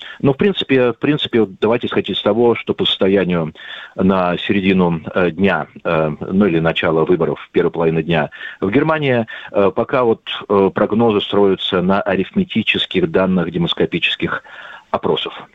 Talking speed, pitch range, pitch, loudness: 130 wpm, 85-125 Hz, 100 Hz, -16 LUFS